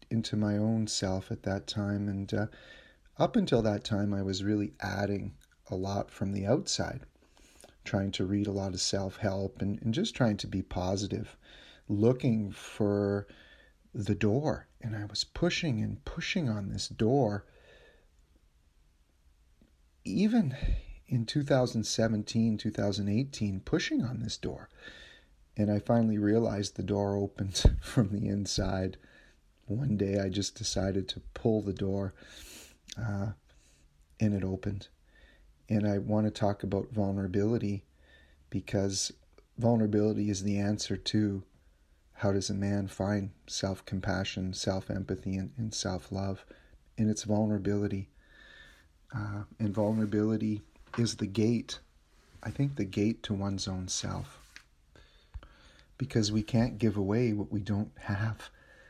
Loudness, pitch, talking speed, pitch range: -32 LUFS, 100 Hz, 130 wpm, 95-110 Hz